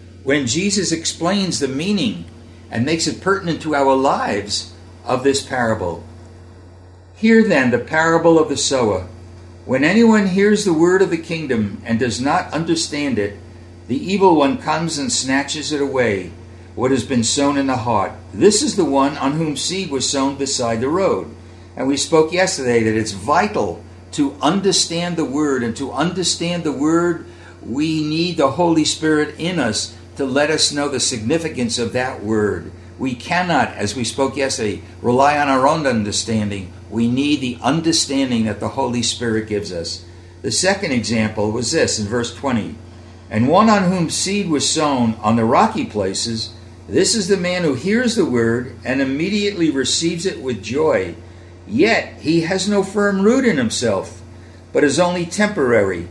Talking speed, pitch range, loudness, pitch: 170 wpm, 105-165 Hz, -18 LUFS, 135 Hz